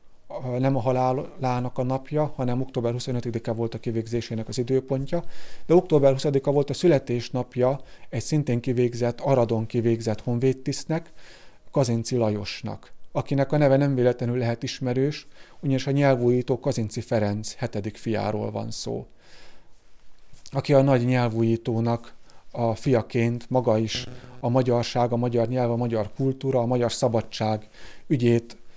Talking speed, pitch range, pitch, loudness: 130 wpm, 115-135 Hz, 125 Hz, -25 LUFS